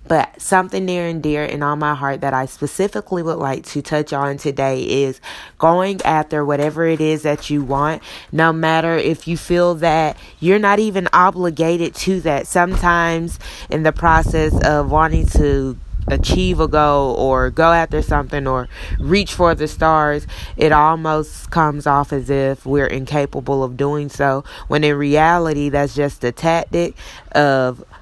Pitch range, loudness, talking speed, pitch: 140-165 Hz, -17 LUFS, 165 wpm, 150 Hz